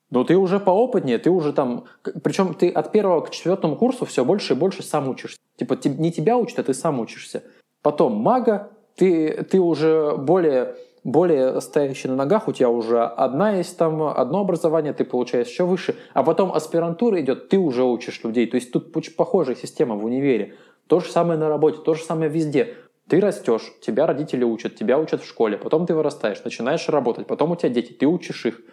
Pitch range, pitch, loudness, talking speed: 140-190 Hz, 160 Hz, -21 LUFS, 200 wpm